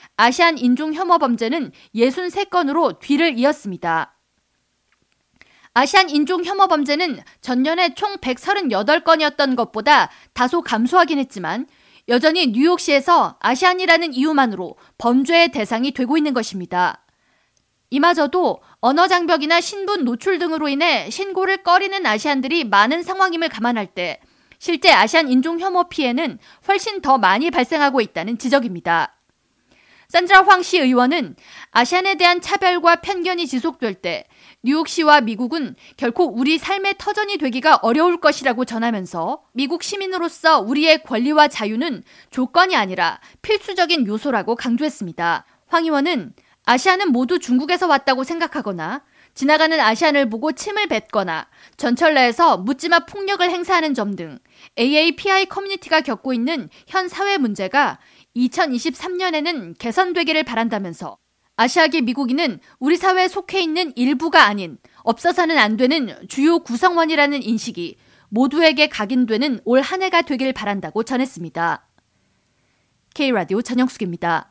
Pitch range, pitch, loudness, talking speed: 240-345 Hz, 295 Hz, -18 LUFS, 325 characters per minute